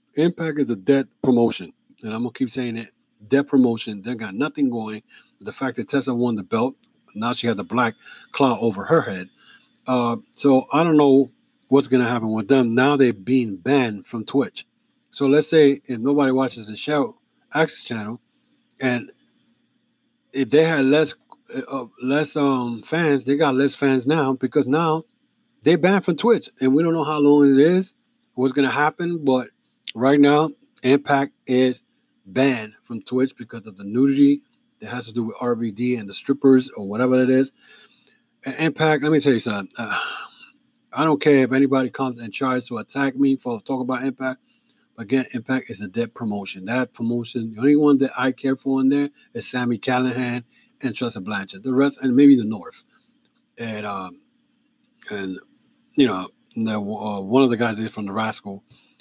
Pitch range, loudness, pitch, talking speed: 120-150 Hz, -21 LUFS, 135 Hz, 185 wpm